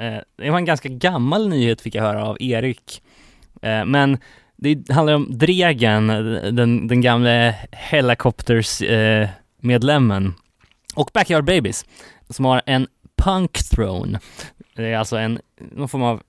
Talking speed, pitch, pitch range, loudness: 125 wpm, 120 Hz, 110-135 Hz, -19 LUFS